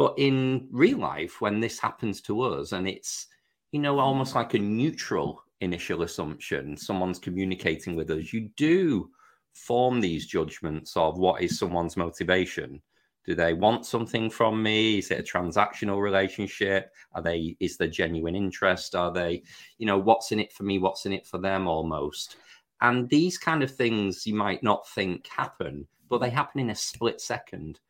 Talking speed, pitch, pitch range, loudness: 175 wpm, 100 Hz, 90-115 Hz, -27 LUFS